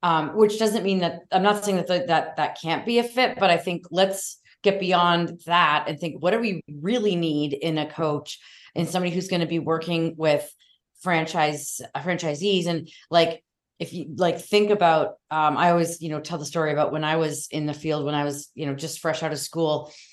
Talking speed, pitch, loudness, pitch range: 225 wpm, 165 Hz, -24 LUFS, 155-180 Hz